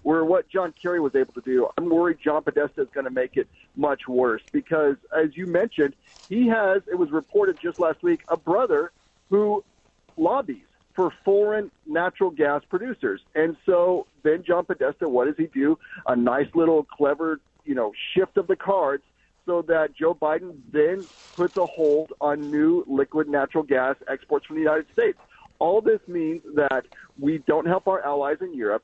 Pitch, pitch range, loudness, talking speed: 175 Hz, 155-225 Hz, -24 LUFS, 185 wpm